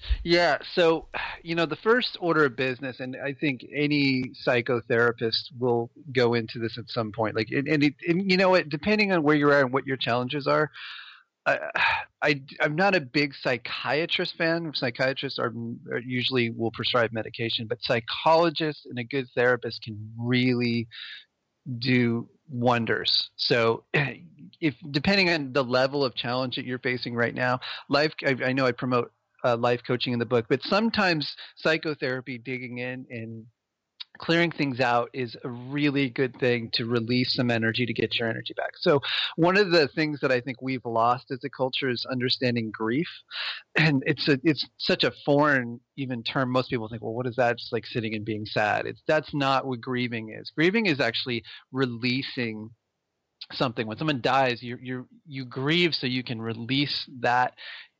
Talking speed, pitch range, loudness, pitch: 180 wpm, 120-150 Hz, -26 LUFS, 130 Hz